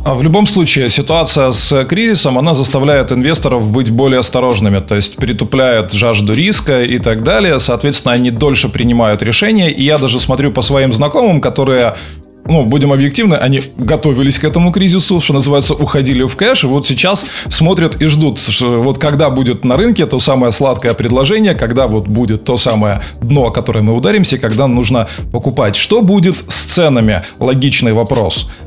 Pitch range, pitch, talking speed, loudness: 120-150 Hz, 130 Hz, 170 wpm, -10 LUFS